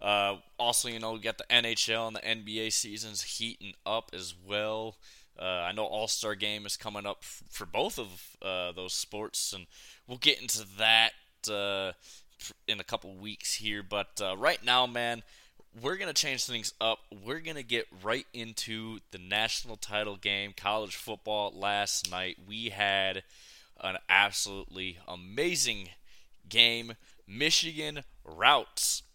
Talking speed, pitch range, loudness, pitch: 150 wpm, 100-115 Hz, -30 LUFS, 110 Hz